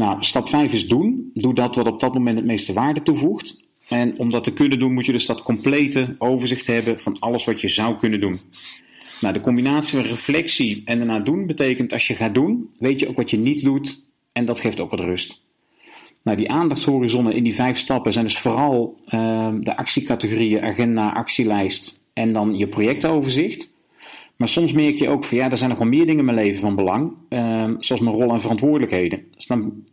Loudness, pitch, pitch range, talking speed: -20 LUFS, 120 Hz, 110-135 Hz, 215 wpm